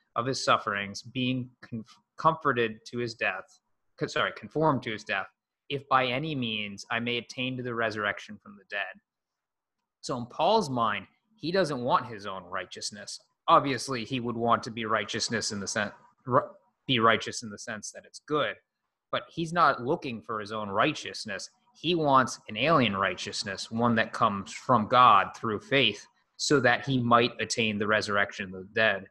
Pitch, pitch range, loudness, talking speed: 120 Hz, 110-130 Hz, -28 LUFS, 175 wpm